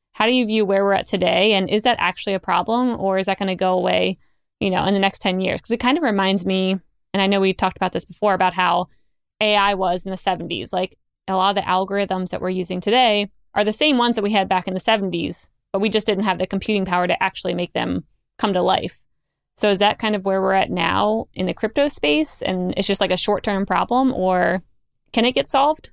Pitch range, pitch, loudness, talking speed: 185-210 Hz, 195 Hz, -20 LUFS, 255 wpm